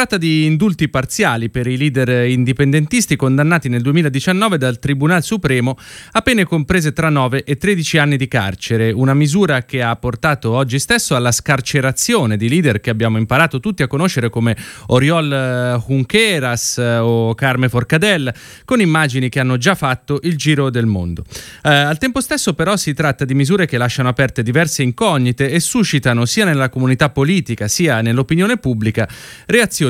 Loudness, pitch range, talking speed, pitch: -15 LUFS, 125-165 Hz, 165 wpm, 135 Hz